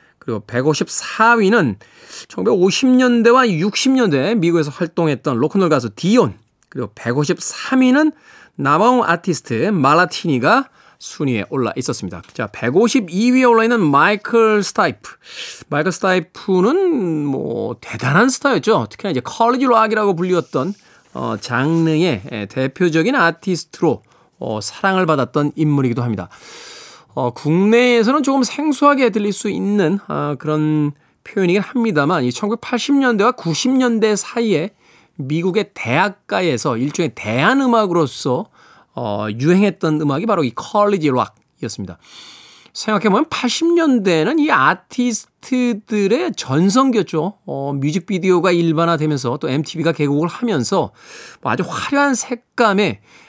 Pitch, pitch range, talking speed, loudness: 185 Hz, 150-235 Hz, 285 characters per minute, -16 LUFS